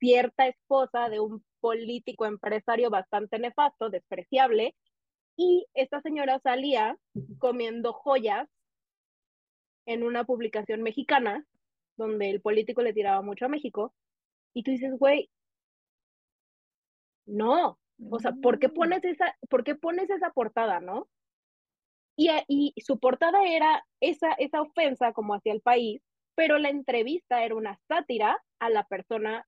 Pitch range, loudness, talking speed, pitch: 225-285 Hz, -27 LUFS, 130 wpm, 245 Hz